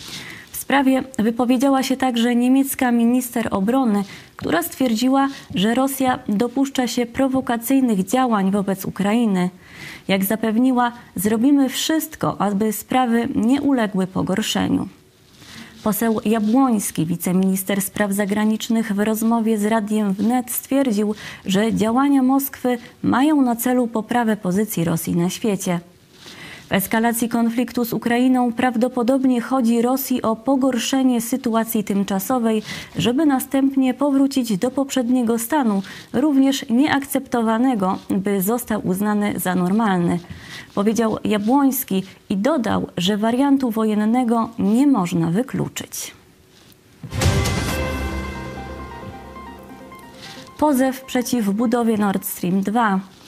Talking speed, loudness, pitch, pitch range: 100 wpm, -19 LUFS, 230 Hz, 205-260 Hz